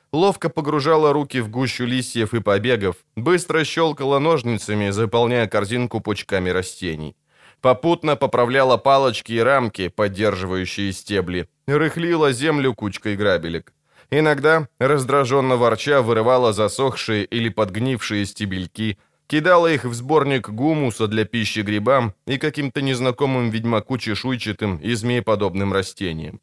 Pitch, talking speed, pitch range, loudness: 120 Hz, 110 wpm, 105-140 Hz, -20 LUFS